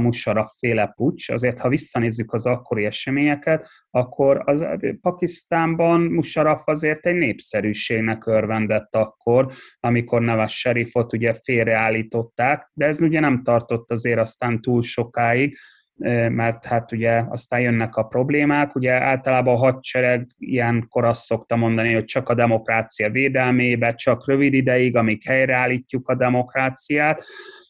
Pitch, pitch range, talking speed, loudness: 125 Hz, 115-135 Hz, 130 wpm, -20 LUFS